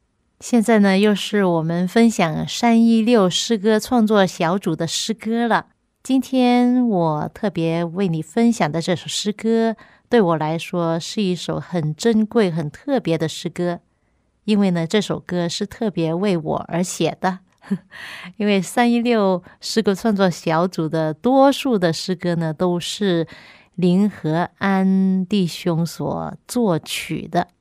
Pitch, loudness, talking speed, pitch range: 190 Hz, -19 LUFS, 205 characters per minute, 170-225 Hz